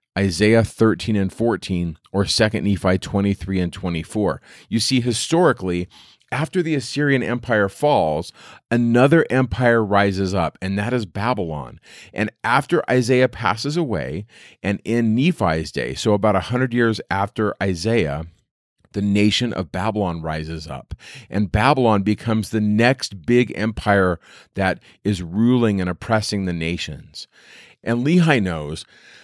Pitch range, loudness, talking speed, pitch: 95-120 Hz, -20 LUFS, 130 wpm, 105 Hz